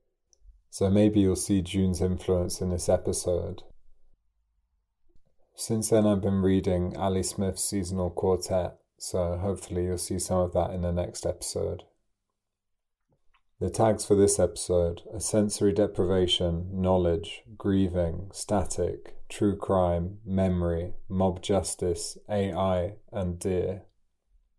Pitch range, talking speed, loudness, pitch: 90-100 Hz, 115 wpm, -27 LUFS, 95 Hz